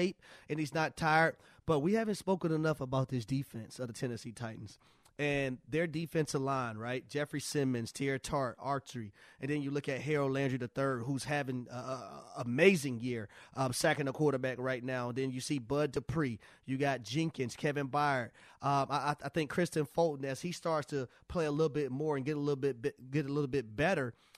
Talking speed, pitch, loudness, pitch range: 200 wpm, 140 Hz, -35 LUFS, 130-155 Hz